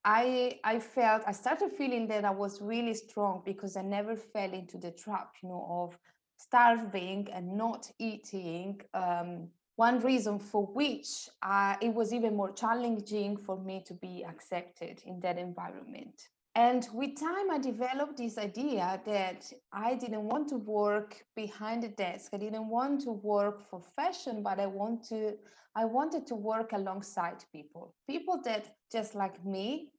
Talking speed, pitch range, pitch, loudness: 165 wpm, 195-235 Hz, 215 Hz, -34 LUFS